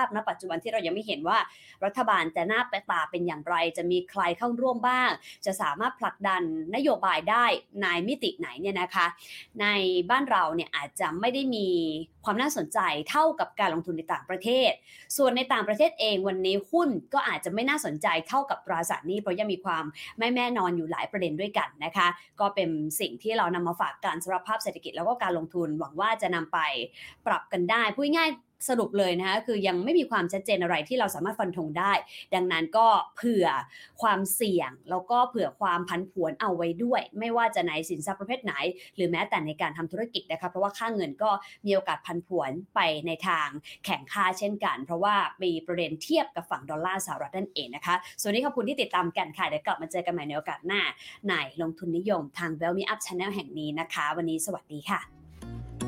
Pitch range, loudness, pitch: 170-225 Hz, -28 LUFS, 185 Hz